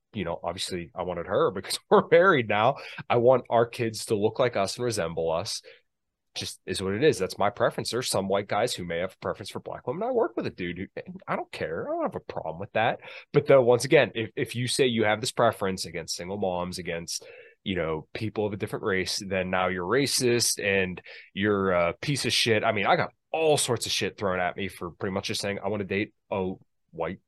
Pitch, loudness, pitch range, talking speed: 110 Hz, -26 LUFS, 95-125 Hz, 245 wpm